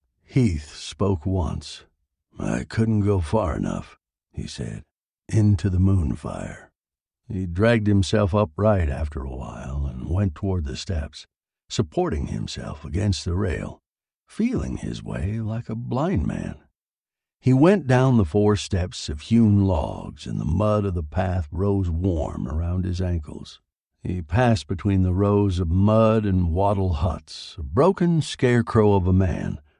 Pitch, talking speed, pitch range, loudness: 95 Hz, 150 wpm, 85-105 Hz, -23 LUFS